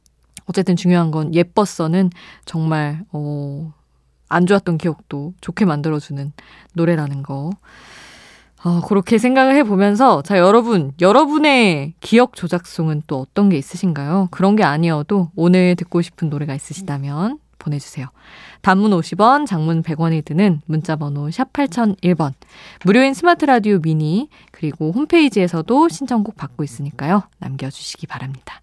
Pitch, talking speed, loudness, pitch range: 175 Hz, 310 characters per minute, -17 LUFS, 150-200 Hz